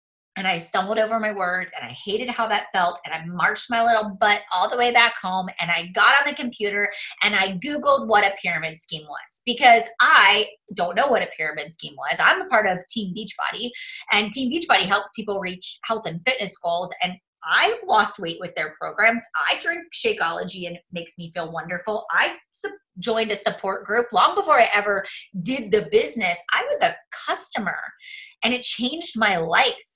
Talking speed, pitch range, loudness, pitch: 200 wpm, 180-240 Hz, -21 LUFS, 210 Hz